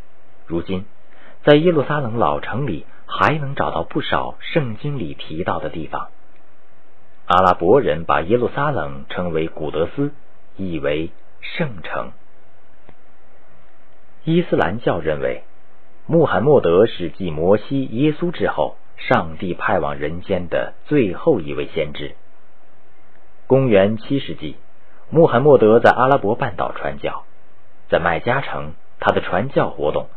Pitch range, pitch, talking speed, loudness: 85-135 Hz, 95 Hz, 200 characters per minute, -19 LUFS